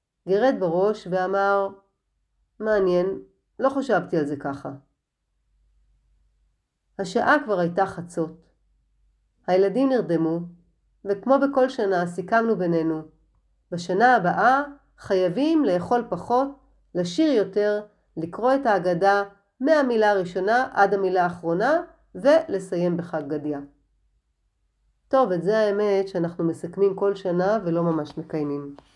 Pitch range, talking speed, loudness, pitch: 165-215 Hz, 100 wpm, -23 LUFS, 190 Hz